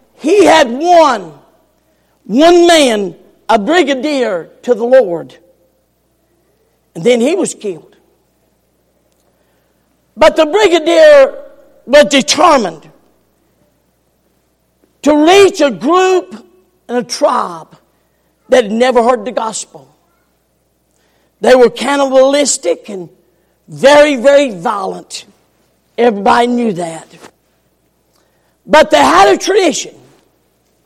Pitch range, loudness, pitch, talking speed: 225-305 Hz, -10 LUFS, 265 Hz, 95 wpm